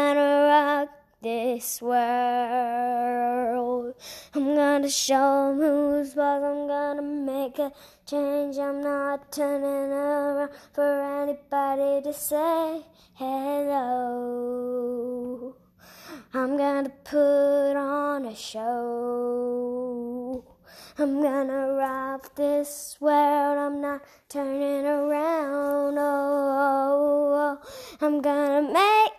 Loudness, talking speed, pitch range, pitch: -25 LUFS, 95 wpm, 260-290 Hz, 280 Hz